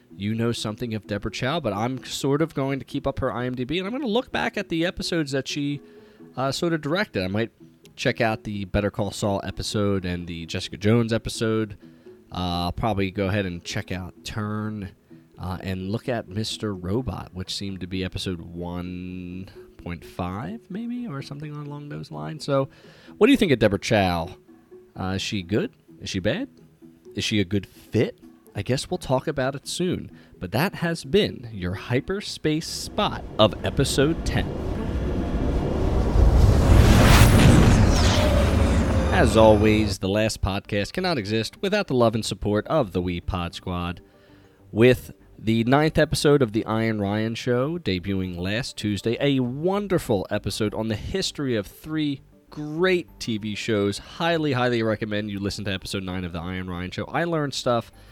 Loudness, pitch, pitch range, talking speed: -24 LUFS, 105 Hz, 95-130 Hz, 170 wpm